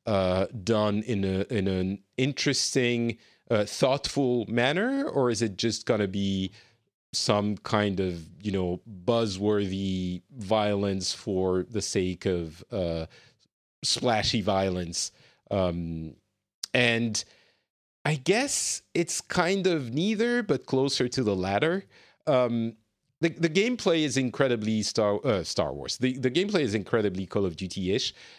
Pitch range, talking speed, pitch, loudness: 95-135 Hz, 130 wpm, 110 Hz, -27 LUFS